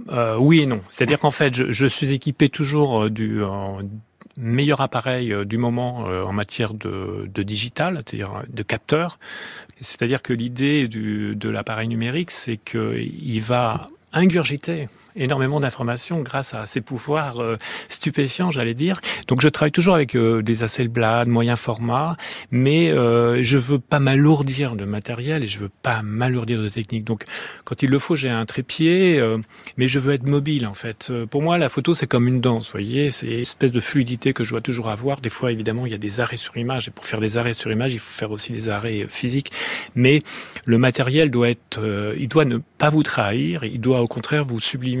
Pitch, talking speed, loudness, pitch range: 125 Hz, 195 wpm, -21 LUFS, 115-140 Hz